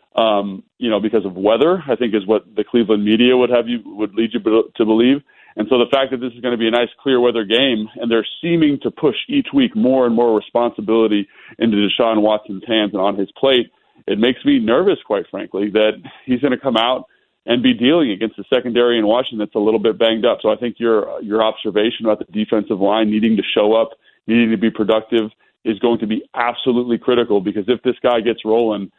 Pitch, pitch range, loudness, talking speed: 115 Hz, 110-125 Hz, -17 LUFS, 230 wpm